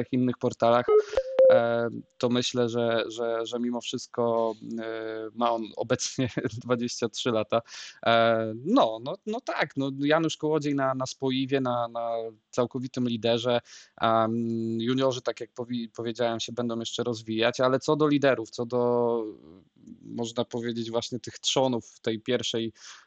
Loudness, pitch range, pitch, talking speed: -27 LUFS, 115-130 Hz, 120 Hz, 130 wpm